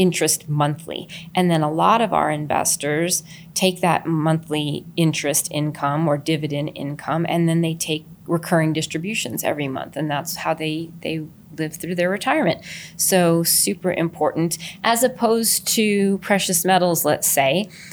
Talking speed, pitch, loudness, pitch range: 145 wpm, 165 Hz, -20 LUFS, 155-180 Hz